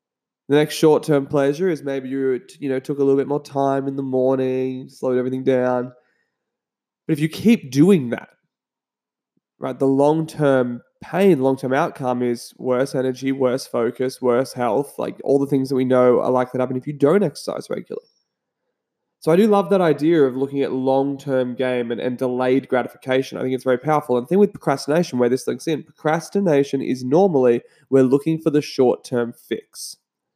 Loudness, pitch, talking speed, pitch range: -20 LUFS, 135 Hz, 185 wpm, 130-155 Hz